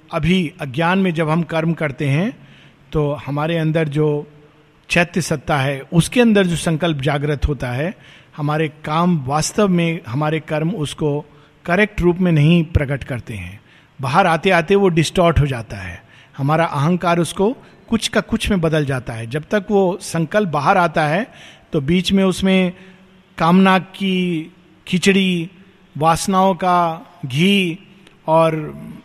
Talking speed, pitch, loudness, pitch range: 150 wpm, 165 Hz, -17 LUFS, 150-185 Hz